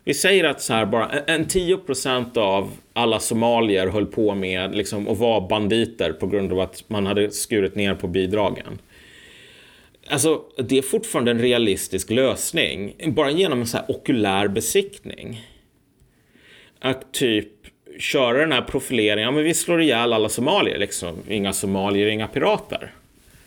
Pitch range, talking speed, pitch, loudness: 100-135 Hz, 155 wpm, 110 Hz, -21 LUFS